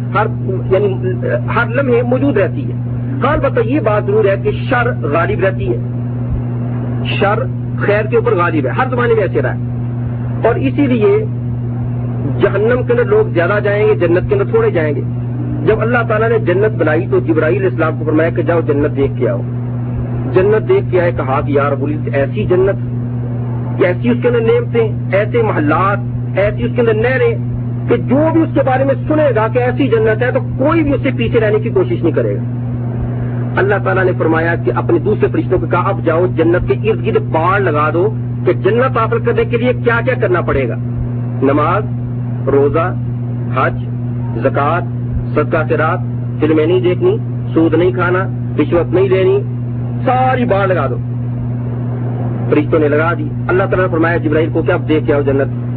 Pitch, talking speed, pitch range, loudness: 120 Hz, 190 wpm, 120-130 Hz, -14 LUFS